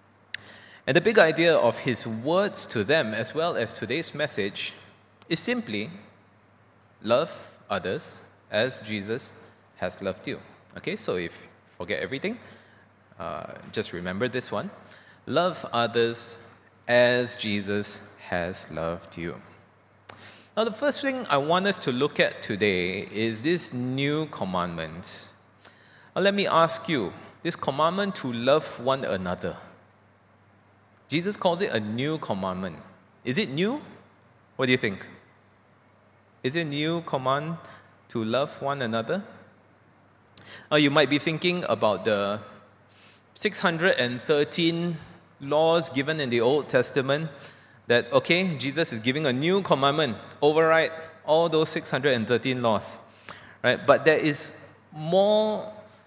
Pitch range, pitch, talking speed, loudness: 100-155 Hz, 120 Hz, 130 wpm, -26 LUFS